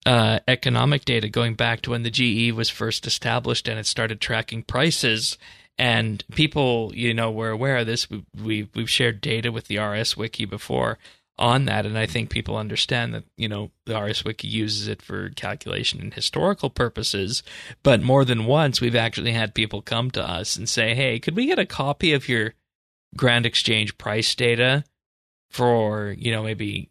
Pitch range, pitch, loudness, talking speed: 110-125 Hz, 115 Hz, -22 LUFS, 190 wpm